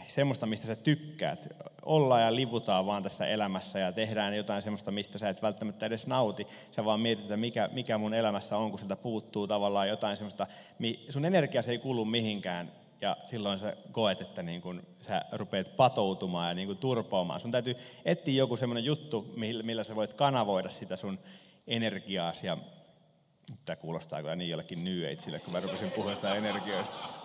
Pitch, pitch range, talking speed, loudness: 110 Hz, 100-120 Hz, 170 wpm, -32 LUFS